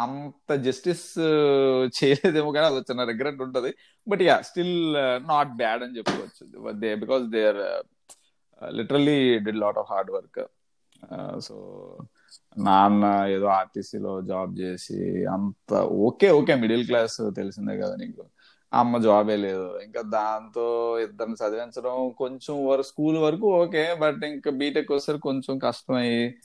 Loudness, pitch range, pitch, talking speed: -24 LUFS, 110-150 Hz, 130 Hz, 125 wpm